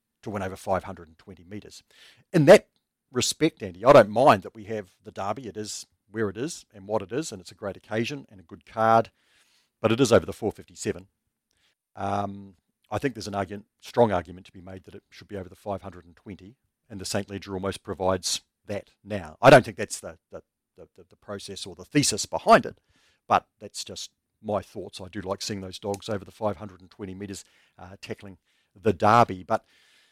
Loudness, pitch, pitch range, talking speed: -25 LUFS, 100 Hz, 95-105 Hz, 205 wpm